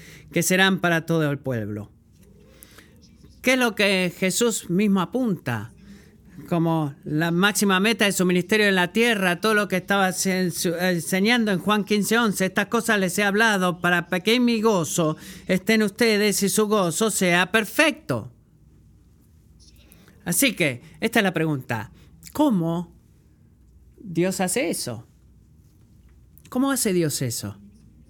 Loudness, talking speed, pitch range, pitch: -22 LUFS, 135 wpm, 165-210 Hz, 185 Hz